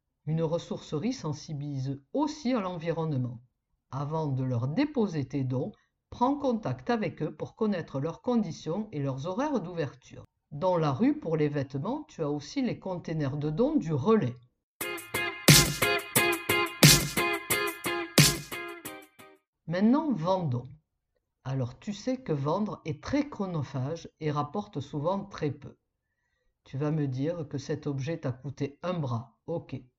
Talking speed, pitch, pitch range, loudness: 130 wpm, 155 Hz, 135-195 Hz, -29 LUFS